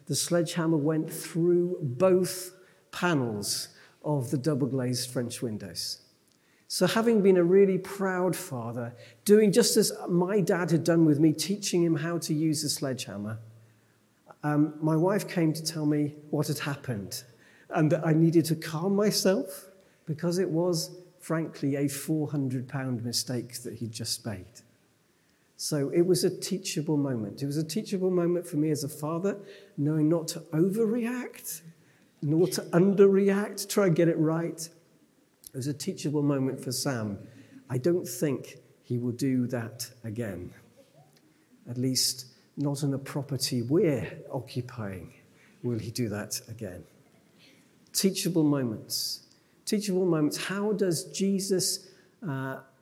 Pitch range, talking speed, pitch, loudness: 130-180 Hz, 145 wpm, 155 Hz, -28 LUFS